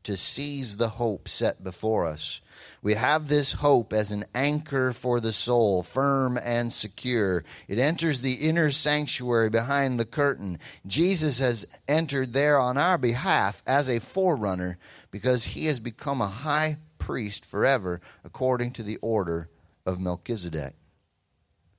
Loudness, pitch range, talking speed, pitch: -26 LUFS, 105-140 Hz, 145 wpm, 120 Hz